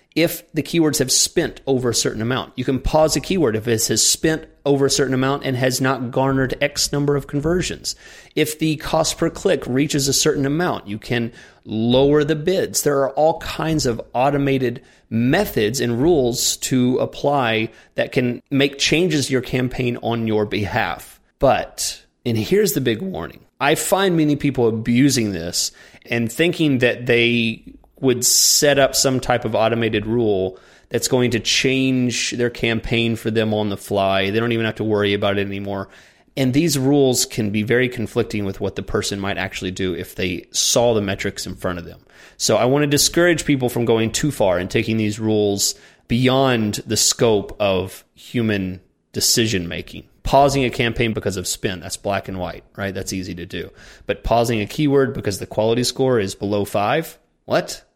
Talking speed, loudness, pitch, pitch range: 185 wpm, -19 LUFS, 120 Hz, 105-140 Hz